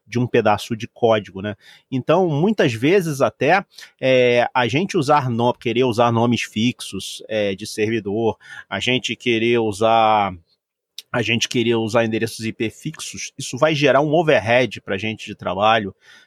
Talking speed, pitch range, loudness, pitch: 160 wpm, 110-125 Hz, -19 LUFS, 115 Hz